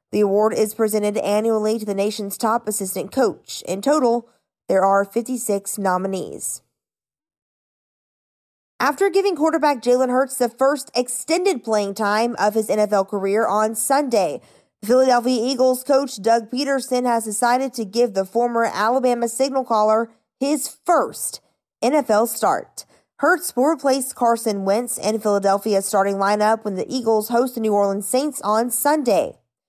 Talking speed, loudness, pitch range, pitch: 140 wpm, -20 LUFS, 210-255 Hz, 230 Hz